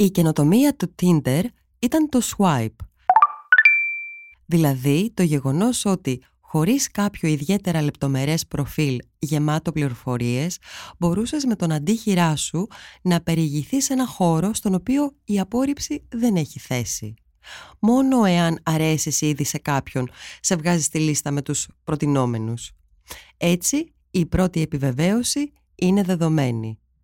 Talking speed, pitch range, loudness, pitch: 120 wpm, 145-215 Hz, -21 LUFS, 170 Hz